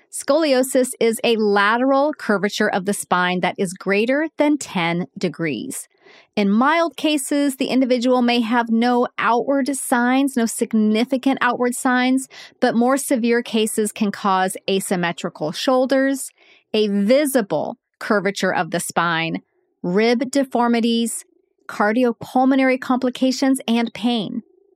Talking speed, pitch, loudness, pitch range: 115 wpm, 240 Hz, -19 LUFS, 210-270 Hz